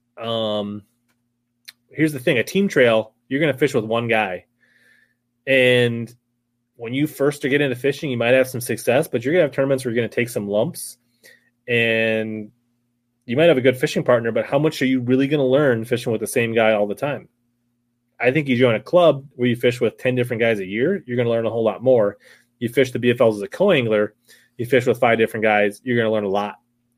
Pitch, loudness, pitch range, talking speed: 120 Hz, -19 LUFS, 115-130 Hz, 240 wpm